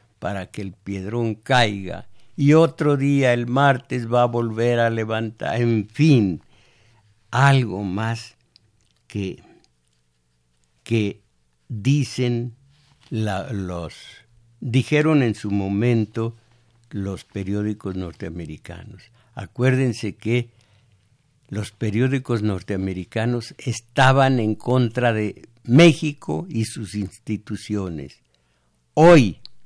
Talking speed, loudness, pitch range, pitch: 90 wpm, -21 LUFS, 100-125 Hz, 115 Hz